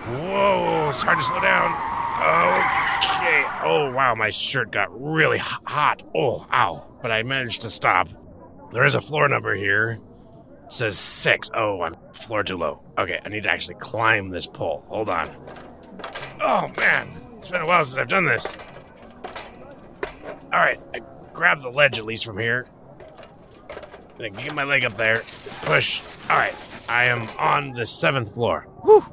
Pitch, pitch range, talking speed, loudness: 115 Hz, 110-135 Hz, 165 wpm, -21 LUFS